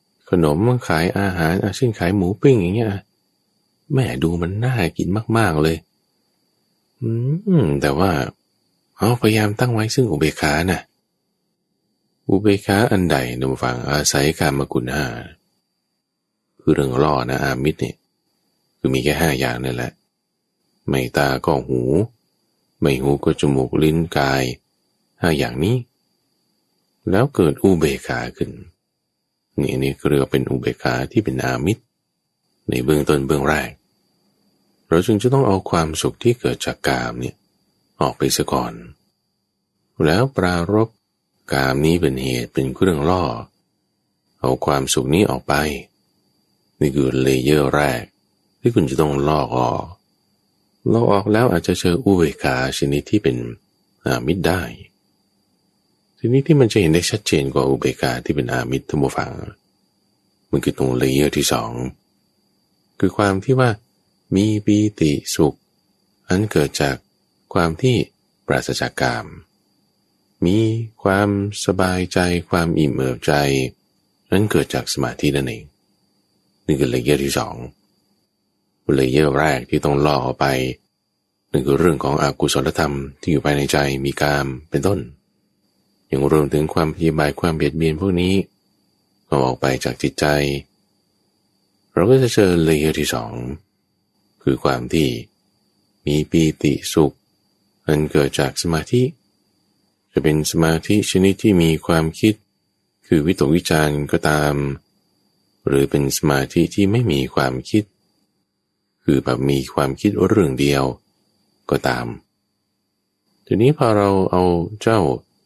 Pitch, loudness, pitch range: 80 Hz, -19 LUFS, 70-100 Hz